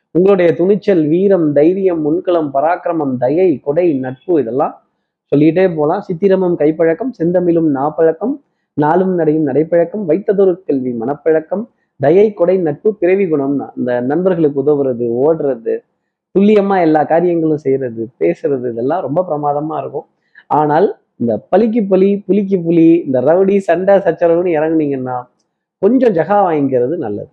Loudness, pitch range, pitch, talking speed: -14 LUFS, 145-190 Hz, 165 Hz, 120 wpm